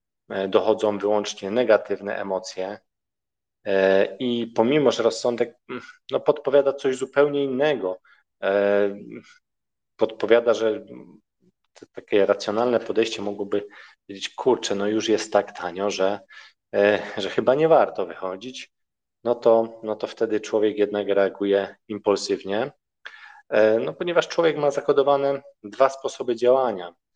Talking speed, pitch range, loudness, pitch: 110 wpm, 100-125 Hz, -23 LUFS, 105 Hz